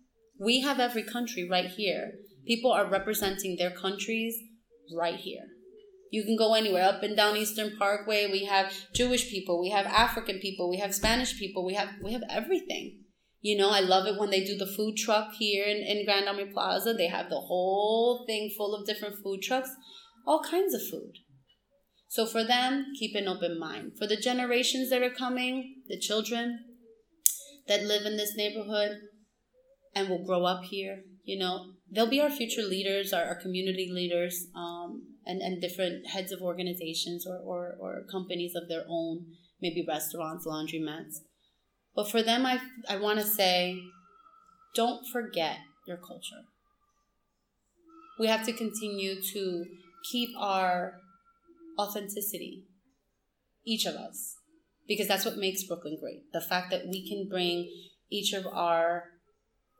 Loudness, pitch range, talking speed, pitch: -30 LUFS, 185-230 Hz, 160 wpm, 205 Hz